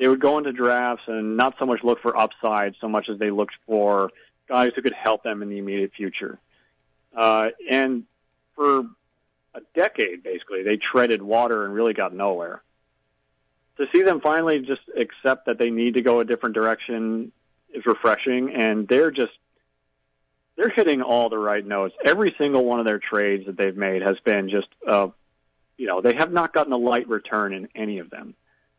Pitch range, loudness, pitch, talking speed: 100-125 Hz, -22 LUFS, 110 Hz, 190 wpm